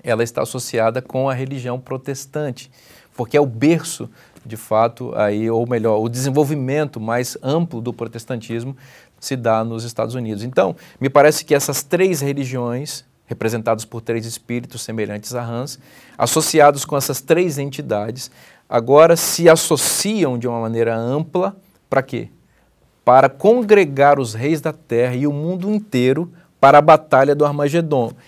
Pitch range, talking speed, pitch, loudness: 115-150 Hz, 150 wpm, 130 Hz, -17 LUFS